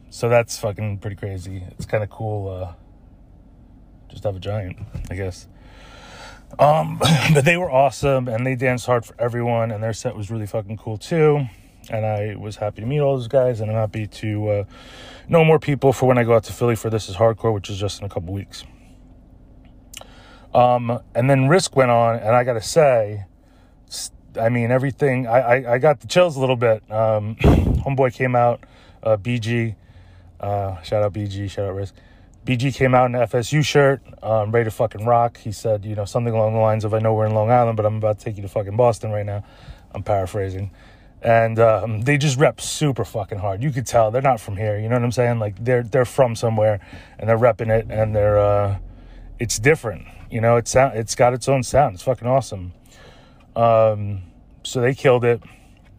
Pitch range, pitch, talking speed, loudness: 105-125 Hz, 110 Hz, 210 wpm, -20 LUFS